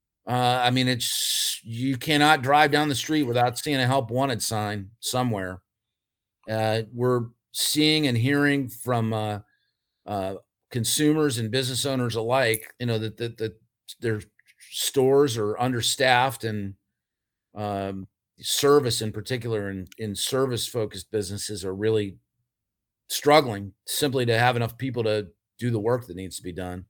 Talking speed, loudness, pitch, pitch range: 150 wpm, -24 LUFS, 115 Hz, 105-130 Hz